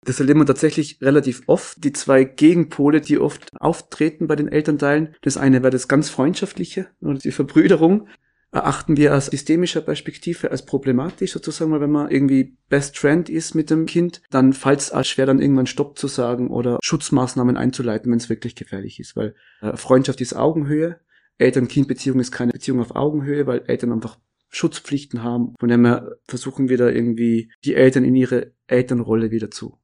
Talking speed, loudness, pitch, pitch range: 175 wpm, -19 LUFS, 140 Hz, 125-155 Hz